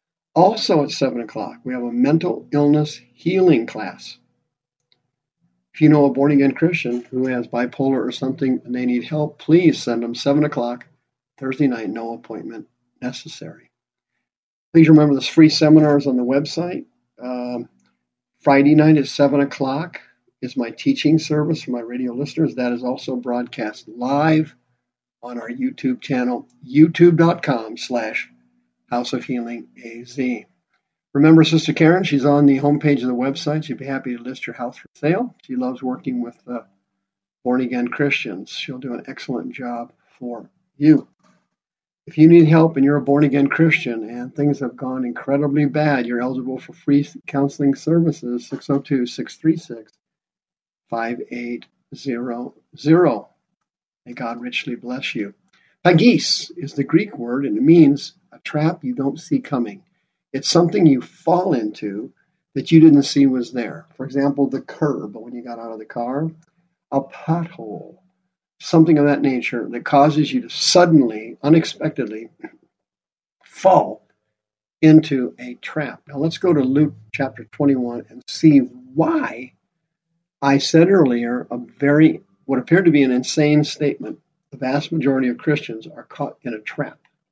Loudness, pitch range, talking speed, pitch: -18 LUFS, 125-155 Hz, 150 wpm, 140 Hz